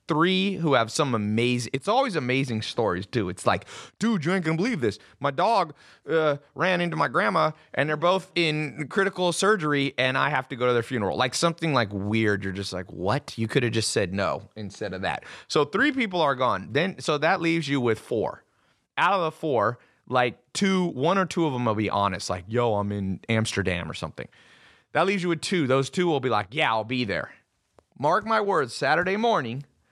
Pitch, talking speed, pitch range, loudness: 135 Hz, 215 wpm, 110-170 Hz, -25 LUFS